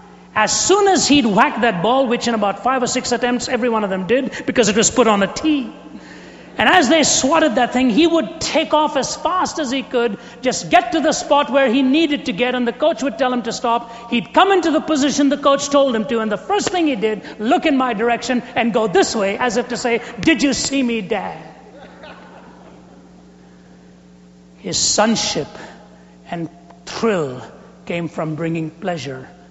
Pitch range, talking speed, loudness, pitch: 210-285 Hz, 205 wpm, -17 LUFS, 245 Hz